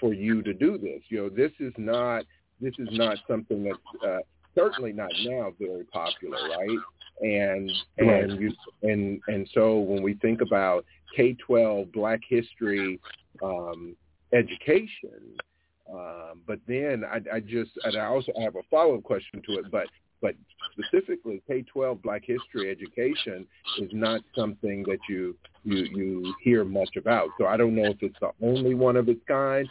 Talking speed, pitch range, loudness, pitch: 165 wpm, 100-120 Hz, -27 LUFS, 105 Hz